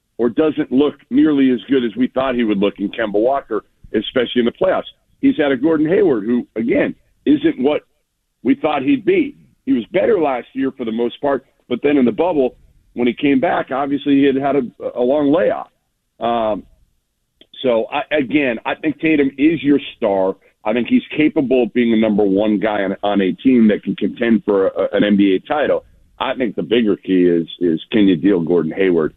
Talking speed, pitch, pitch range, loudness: 210 wpm, 135 Hz, 110-155 Hz, -17 LUFS